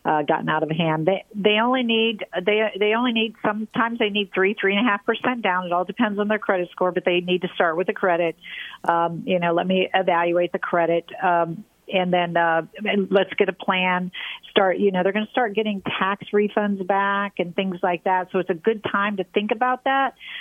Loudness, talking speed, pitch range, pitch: -22 LUFS, 230 wpm, 180-215 Hz, 195 Hz